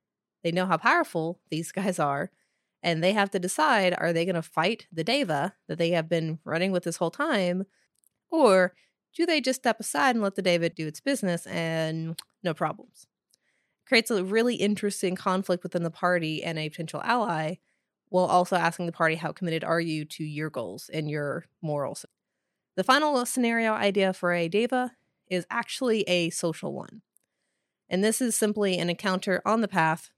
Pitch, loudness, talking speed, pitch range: 180 Hz, -27 LUFS, 185 wpm, 165-210 Hz